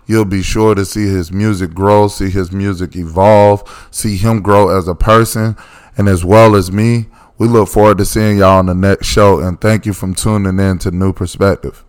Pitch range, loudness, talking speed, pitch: 95-110 Hz, -11 LUFS, 210 wpm, 100 Hz